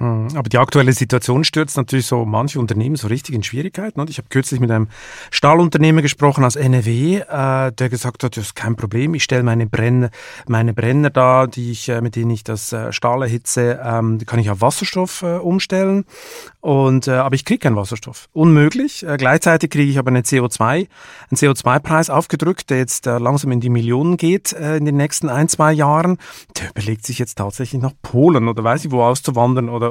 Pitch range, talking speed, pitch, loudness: 120-155 Hz, 185 wpm, 130 Hz, -16 LUFS